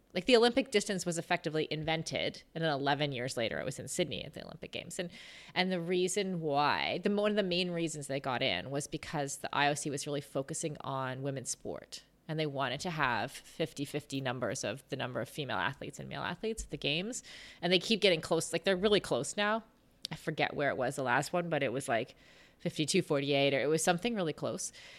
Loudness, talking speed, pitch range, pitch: -33 LUFS, 225 wpm, 140-185 Hz, 160 Hz